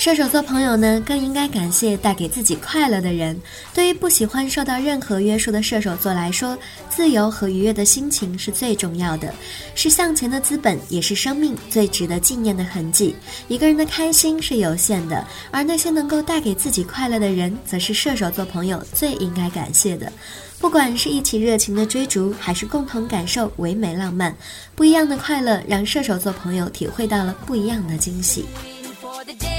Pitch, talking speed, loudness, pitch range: 220 Hz, 295 characters per minute, -19 LUFS, 185-280 Hz